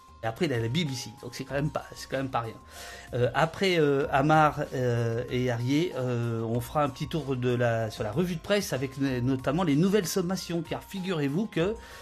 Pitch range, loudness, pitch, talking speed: 120-165 Hz, -28 LUFS, 135 Hz, 230 wpm